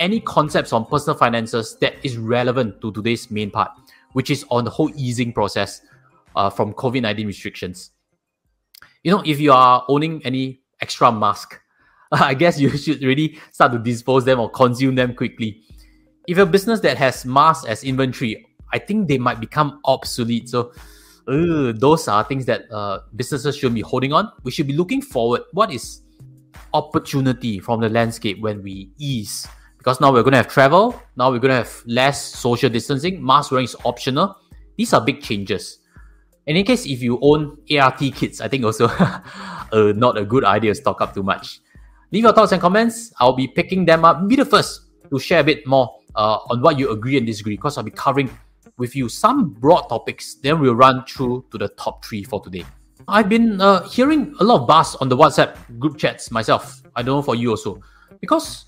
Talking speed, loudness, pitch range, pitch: 195 wpm, -18 LUFS, 115-150 Hz, 130 Hz